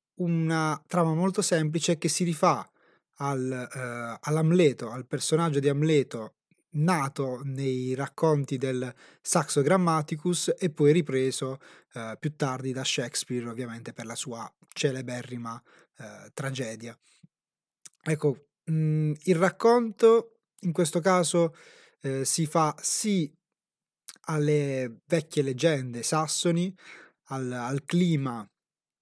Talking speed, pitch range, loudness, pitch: 110 wpm, 130-170 Hz, -27 LUFS, 150 Hz